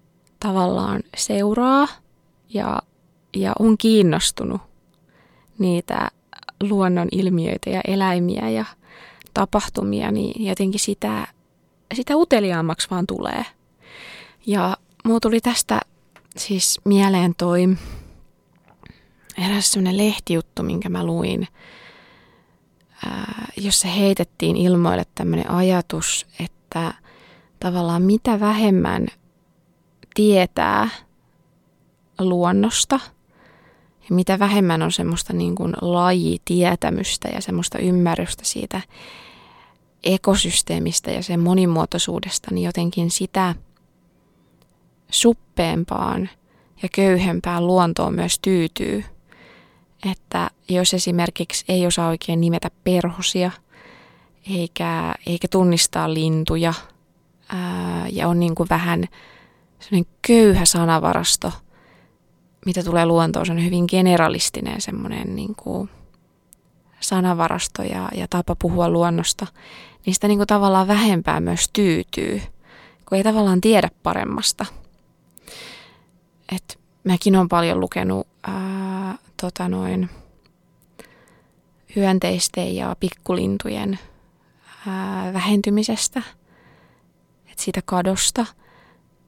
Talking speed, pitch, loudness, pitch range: 85 wpm, 180 Hz, -20 LUFS, 170-200 Hz